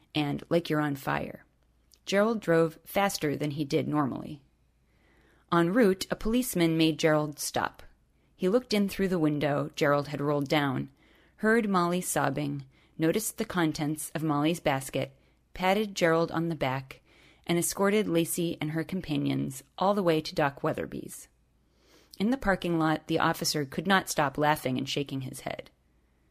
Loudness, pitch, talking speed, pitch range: -28 LUFS, 160 Hz, 155 wpm, 145-180 Hz